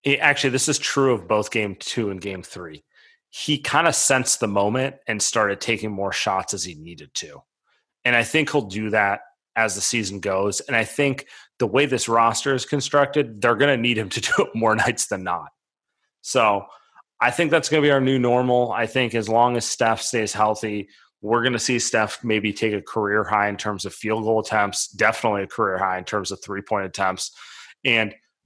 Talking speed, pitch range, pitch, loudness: 215 wpm, 105-130 Hz, 115 Hz, -21 LUFS